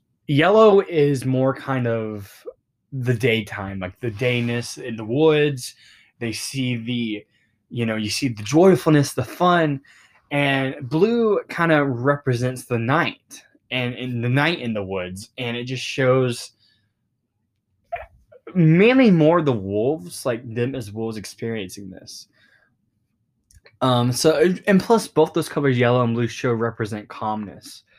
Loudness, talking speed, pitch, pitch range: -20 LUFS, 140 wpm, 125 Hz, 115-145 Hz